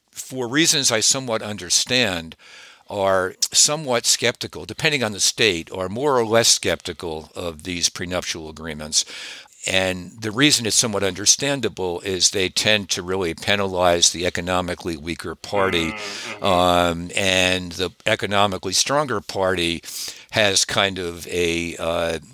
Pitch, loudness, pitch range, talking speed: 95 Hz, -20 LUFS, 85-110 Hz, 130 wpm